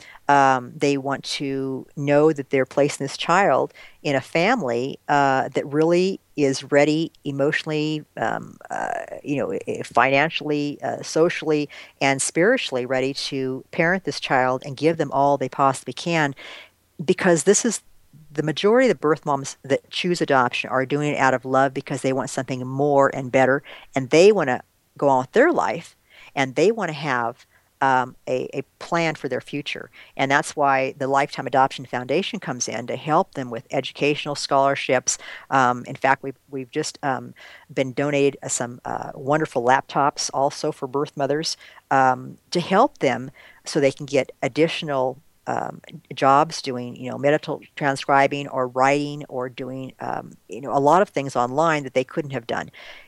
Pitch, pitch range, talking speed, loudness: 140 Hz, 130-150 Hz, 170 wpm, -22 LUFS